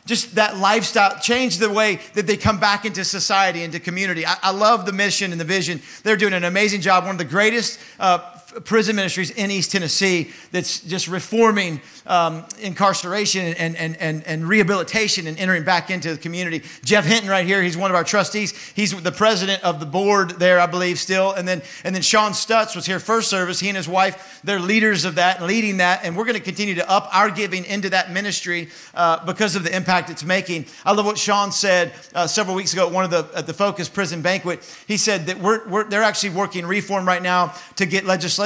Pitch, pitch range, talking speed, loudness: 190 Hz, 180-205 Hz, 225 wpm, -19 LUFS